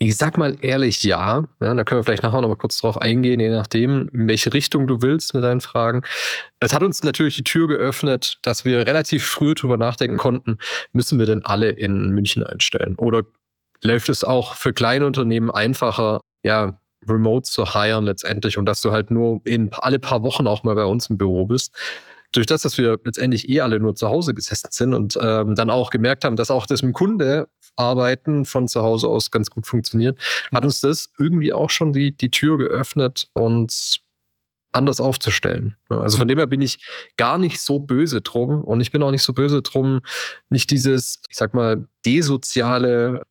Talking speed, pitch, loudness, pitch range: 200 wpm, 125 Hz, -19 LUFS, 115-135 Hz